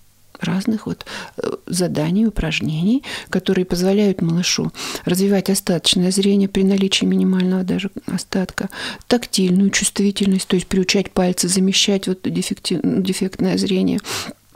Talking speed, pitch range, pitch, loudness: 105 wpm, 185-200 Hz, 190 Hz, -18 LUFS